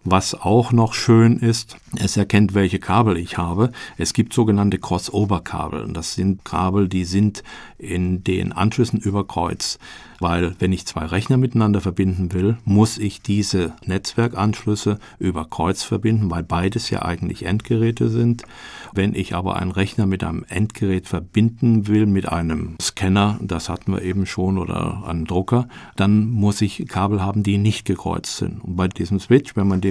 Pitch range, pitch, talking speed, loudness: 90-110 Hz, 100 Hz, 165 wpm, -20 LUFS